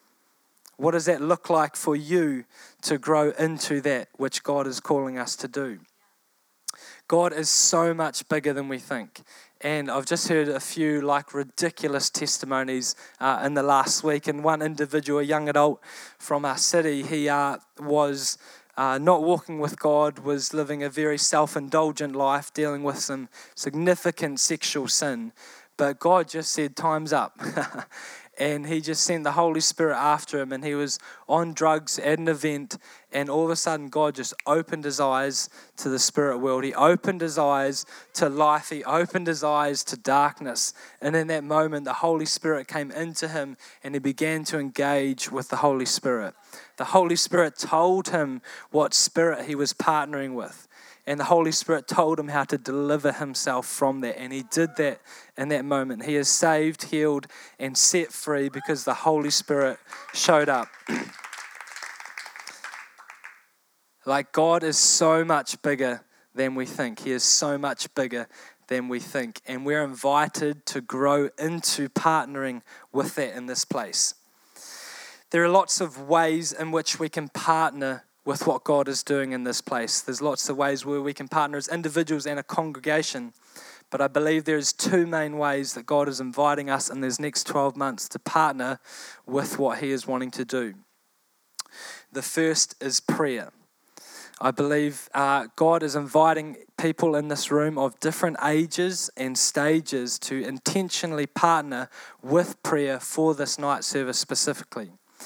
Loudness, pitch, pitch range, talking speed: -25 LUFS, 150 Hz, 140-160 Hz, 170 wpm